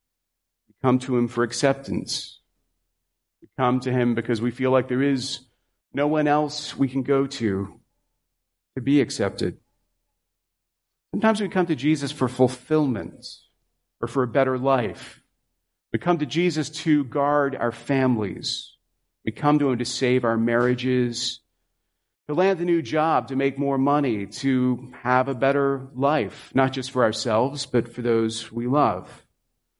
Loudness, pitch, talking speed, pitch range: -23 LUFS, 130 Hz, 155 wpm, 120-140 Hz